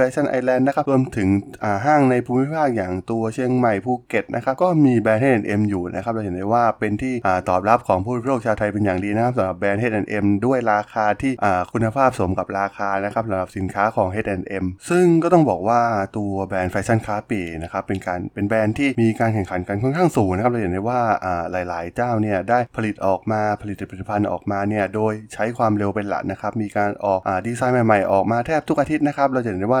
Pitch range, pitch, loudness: 100-125 Hz, 105 Hz, -20 LUFS